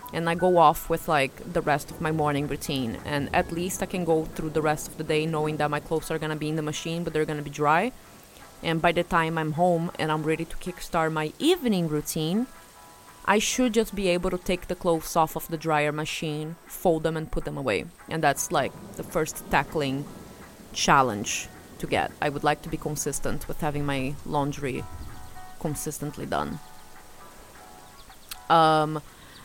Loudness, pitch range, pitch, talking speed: -26 LUFS, 150-170 Hz, 155 Hz, 200 wpm